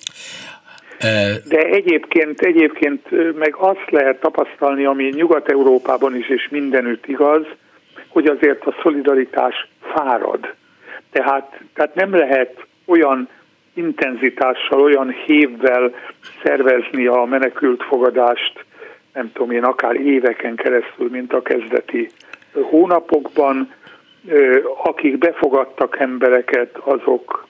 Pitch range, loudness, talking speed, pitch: 130-165 Hz, -16 LUFS, 95 wpm, 140 Hz